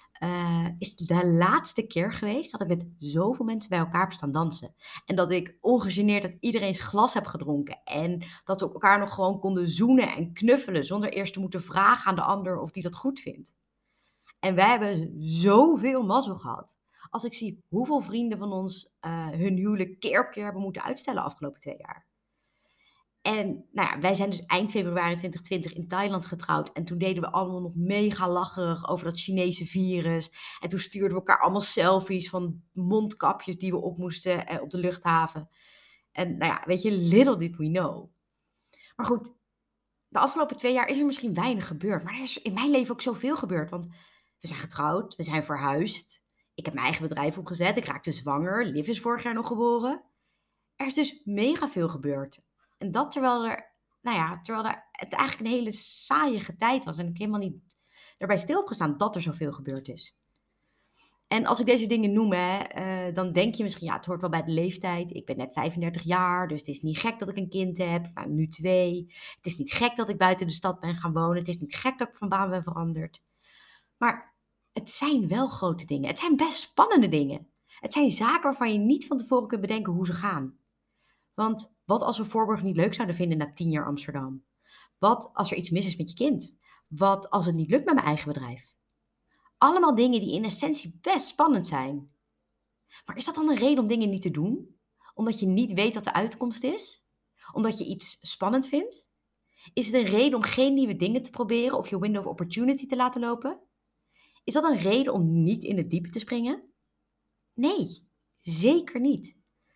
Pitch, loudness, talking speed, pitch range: 190 Hz, -27 LUFS, 205 wpm, 170-235 Hz